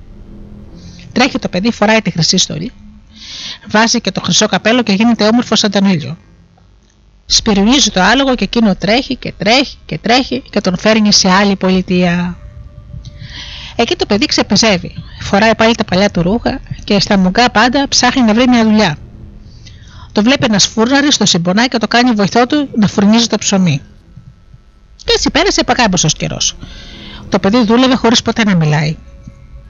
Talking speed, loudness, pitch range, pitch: 160 wpm, -11 LUFS, 160-235 Hz, 205 Hz